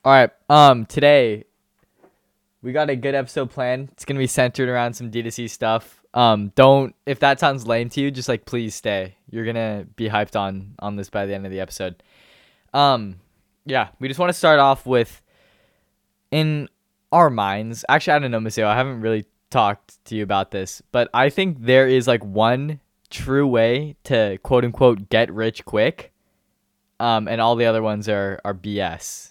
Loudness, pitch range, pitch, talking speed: -19 LUFS, 105-135 Hz, 115 Hz, 185 wpm